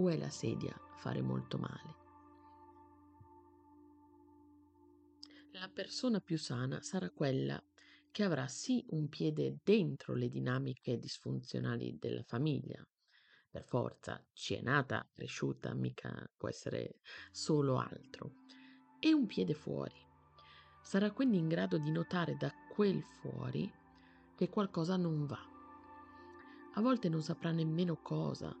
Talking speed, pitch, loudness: 115 wpm, 180 Hz, -38 LUFS